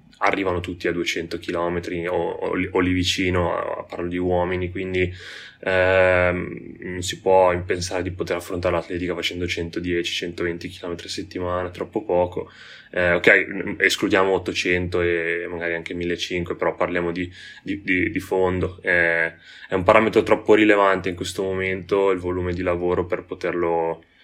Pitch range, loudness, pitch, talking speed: 85-90 Hz, -22 LUFS, 90 Hz, 150 wpm